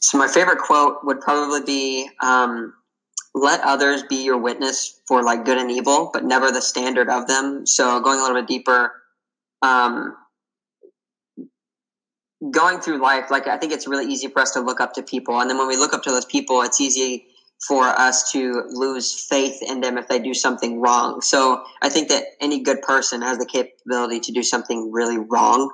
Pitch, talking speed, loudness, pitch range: 130 Hz, 200 wpm, -19 LUFS, 125-135 Hz